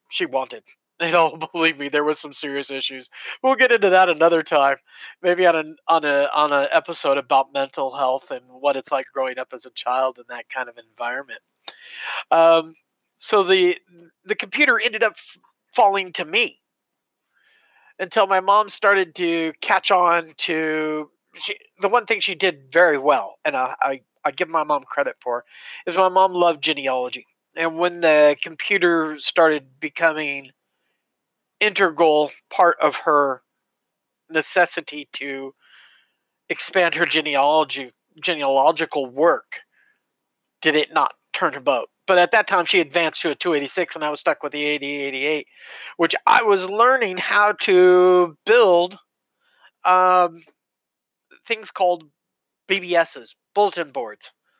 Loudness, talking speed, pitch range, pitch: -19 LUFS, 150 wpm, 145-185 Hz, 165 Hz